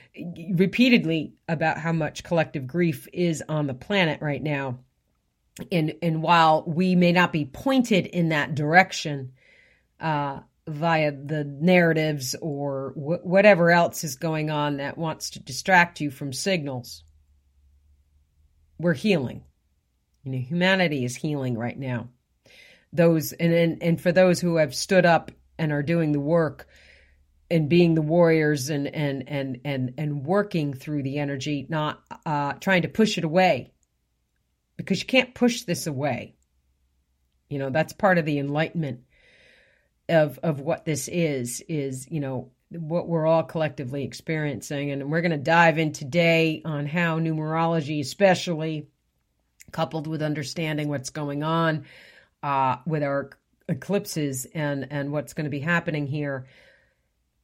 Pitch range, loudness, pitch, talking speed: 140-170 Hz, -24 LUFS, 155 Hz, 145 wpm